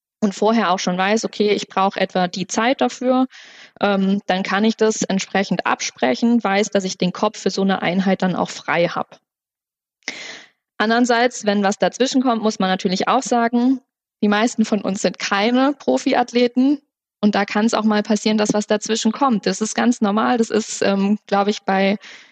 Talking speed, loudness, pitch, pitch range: 190 wpm, -19 LUFS, 215 Hz, 195-235 Hz